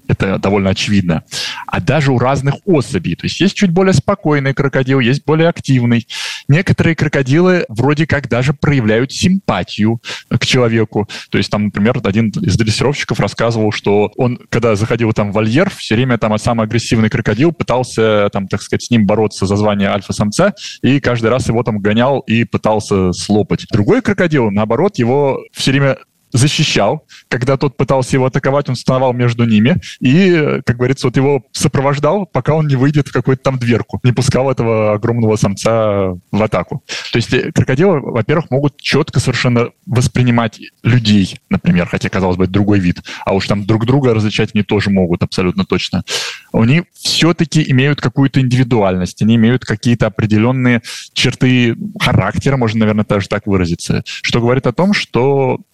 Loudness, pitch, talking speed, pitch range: -14 LUFS, 120 Hz, 165 wpm, 110-140 Hz